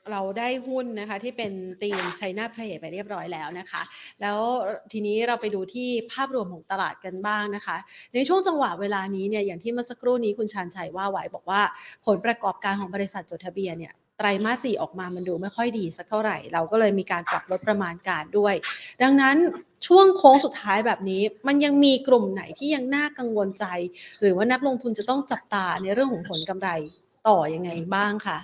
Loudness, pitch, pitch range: -24 LUFS, 205 Hz, 190-240 Hz